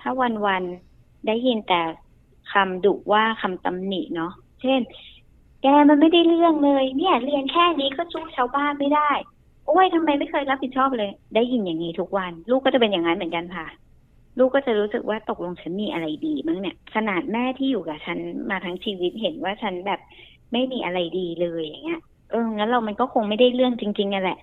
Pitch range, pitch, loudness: 190-275 Hz, 230 Hz, -22 LUFS